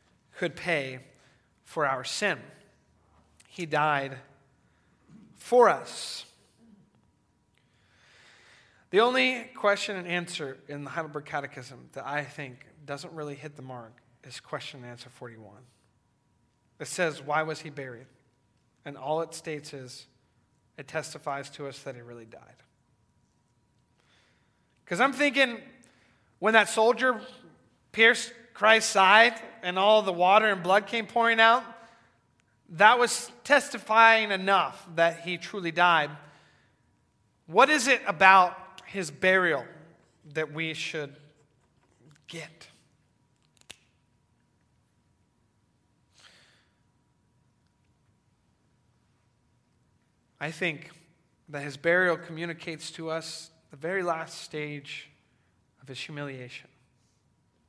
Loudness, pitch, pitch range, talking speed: -25 LUFS, 155 Hz, 135-190 Hz, 105 wpm